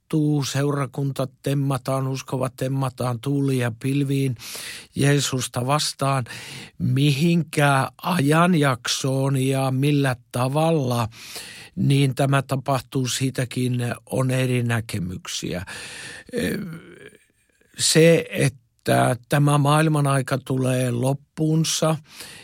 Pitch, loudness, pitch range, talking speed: 135 Hz, -22 LUFS, 130-145 Hz, 75 wpm